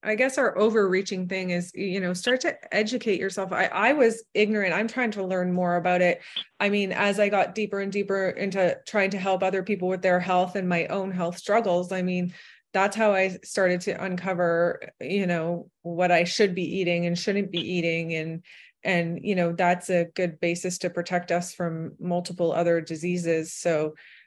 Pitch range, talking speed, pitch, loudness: 175-200 Hz, 200 wpm, 180 Hz, -25 LUFS